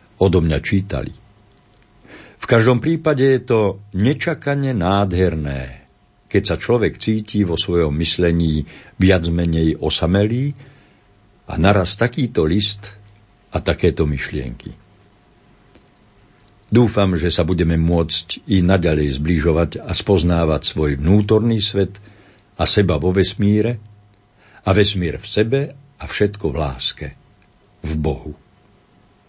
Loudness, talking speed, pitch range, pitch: -18 LUFS, 110 wpm, 85-105 Hz, 100 Hz